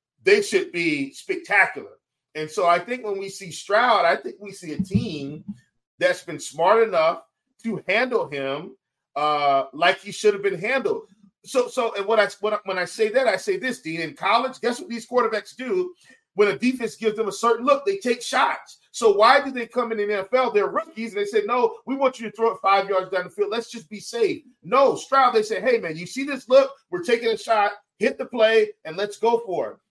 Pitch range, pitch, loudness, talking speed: 195-270 Hz, 225 Hz, -22 LUFS, 230 wpm